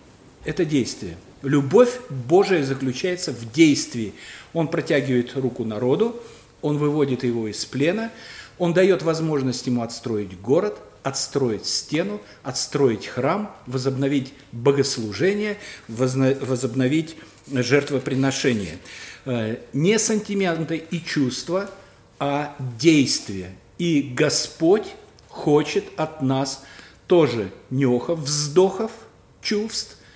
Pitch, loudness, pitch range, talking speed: 140 Hz, -22 LUFS, 125-165 Hz, 90 wpm